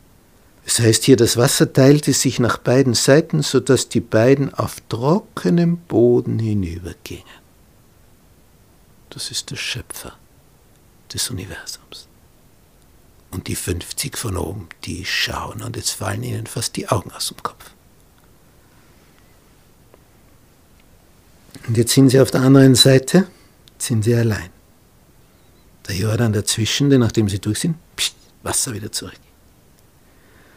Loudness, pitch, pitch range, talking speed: -17 LUFS, 120 Hz, 105-135 Hz, 120 wpm